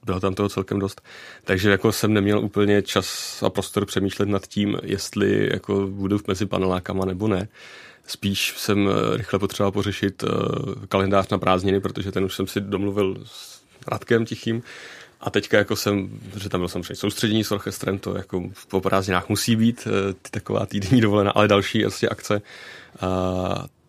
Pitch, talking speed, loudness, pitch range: 100 Hz, 170 wpm, -23 LUFS, 95-105 Hz